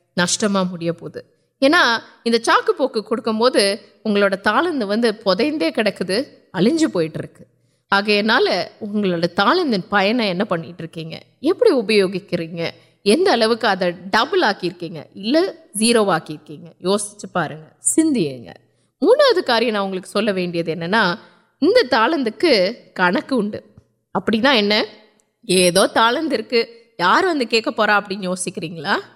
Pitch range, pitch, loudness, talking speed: 180-235 Hz, 205 Hz, -18 LUFS, 70 wpm